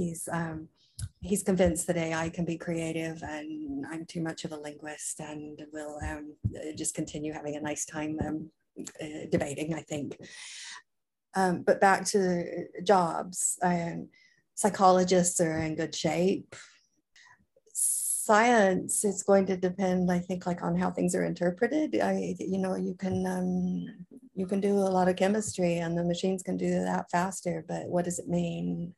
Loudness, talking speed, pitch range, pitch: -29 LUFS, 165 wpm, 155-190 Hz, 175 Hz